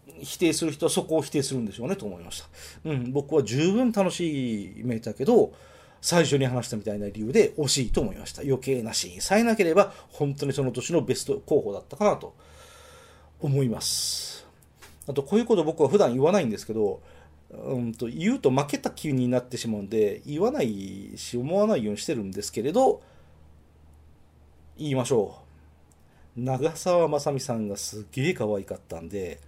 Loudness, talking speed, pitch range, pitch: -26 LUFS, 375 characters per minute, 100-160 Hz, 130 Hz